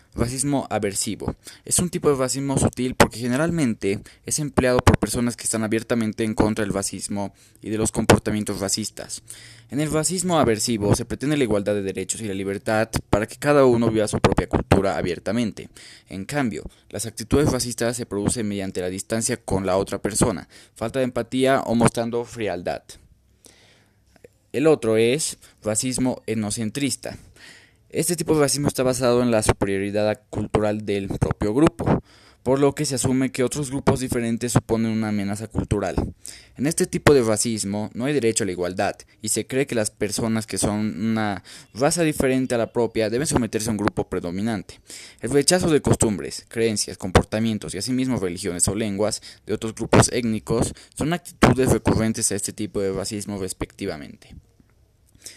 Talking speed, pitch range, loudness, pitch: 165 wpm, 105-125 Hz, -22 LUFS, 110 Hz